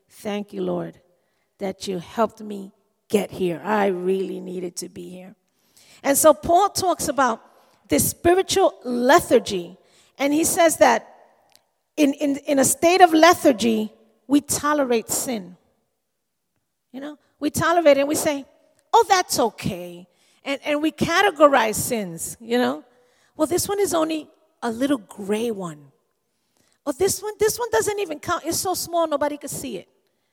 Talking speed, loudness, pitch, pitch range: 155 wpm, -21 LUFS, 275 Hz, 205-320 Hz